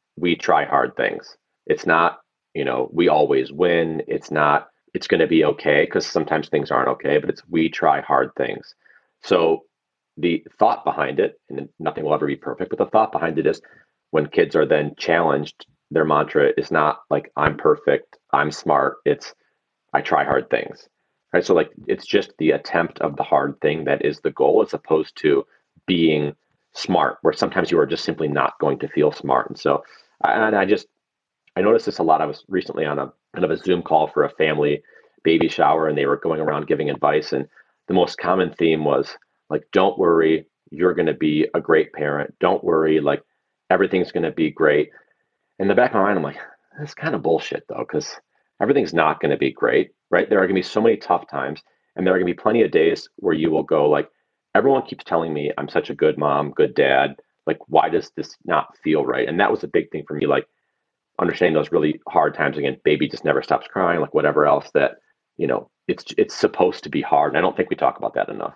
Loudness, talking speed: -20 LUFS, 225 wpm